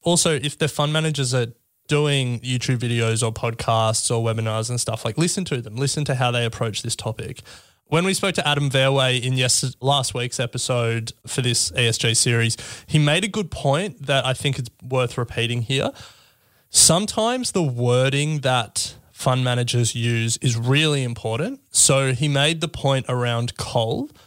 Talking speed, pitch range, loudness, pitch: 170 wpm, 115-145 Hz, -21 LUFS, 125 Hz